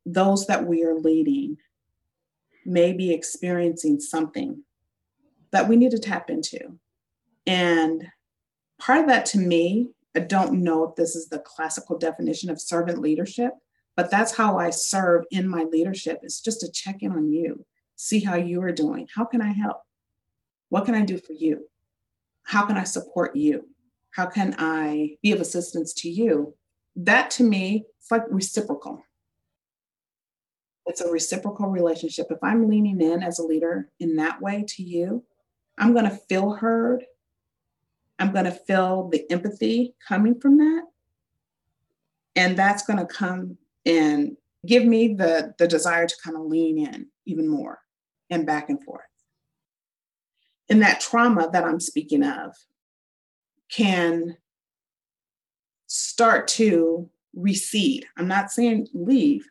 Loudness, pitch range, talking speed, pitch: -23 LUFS, 165-230 Hz, 150 wpm, 185 Hz